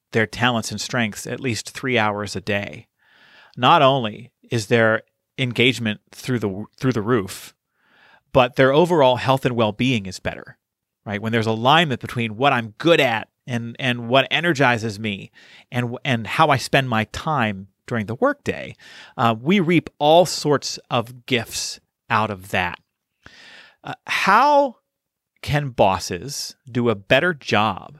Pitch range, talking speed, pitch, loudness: 110-135 Hz, 150 wpm, 120 Hz, -20 LUFS